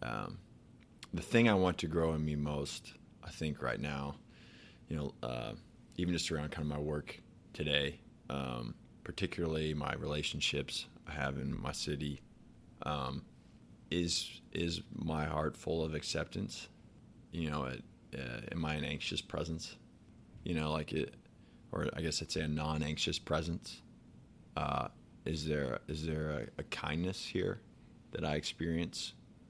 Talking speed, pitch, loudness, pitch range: 155 wpm, 75 Hz, -38 LUFS, 75-85 Hz